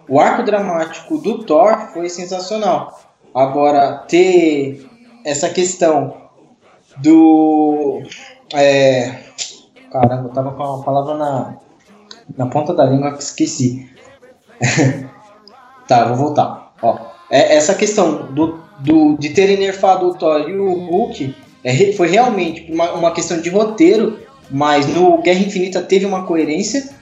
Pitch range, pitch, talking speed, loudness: 140-190 Hz, 165 Hz, 130 wpm, -15 LUFS